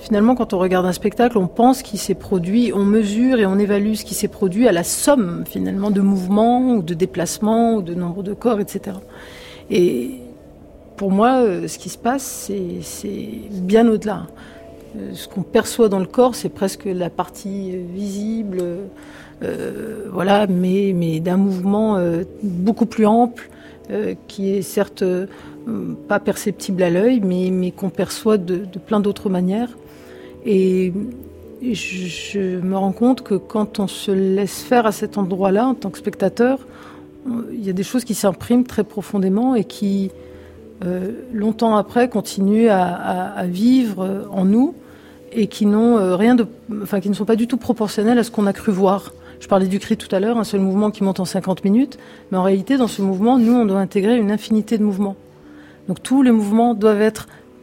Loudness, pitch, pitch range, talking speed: -19 LUFS, 200 Hz, 190-225 Hz, 185 wpm